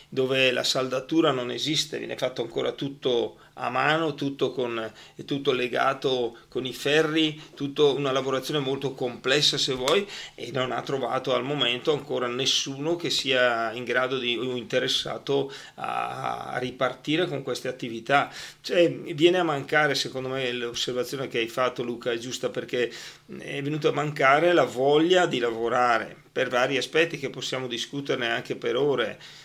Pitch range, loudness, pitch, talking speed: 125-150 Hz, -25 LUFS, 135 Hz, 160 wpm